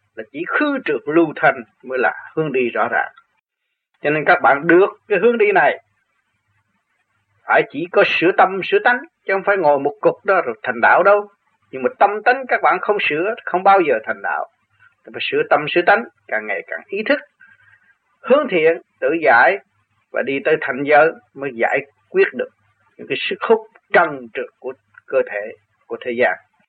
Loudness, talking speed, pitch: -17 LUFS, 195 wpm, 250 Hz